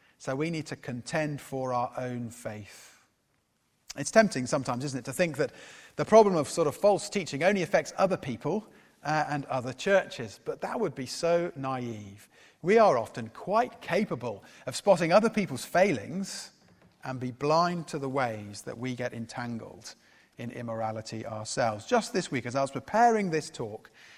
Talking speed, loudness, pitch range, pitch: 175 wpm, -29 LUFS, 120-175 Hz, 140 Hz